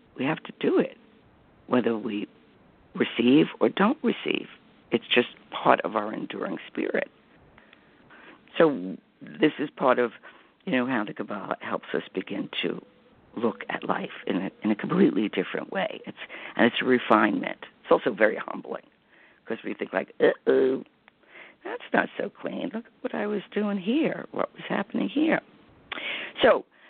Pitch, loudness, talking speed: 225 Hz, -26 LUFS, 160 wpm